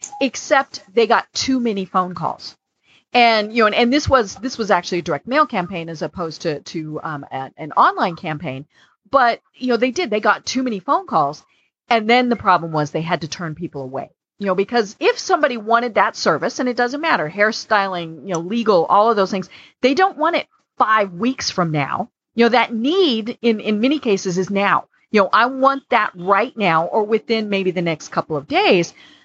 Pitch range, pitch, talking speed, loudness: 175-245 Hz, 210 Hz, 215 wpm, -18 LUFS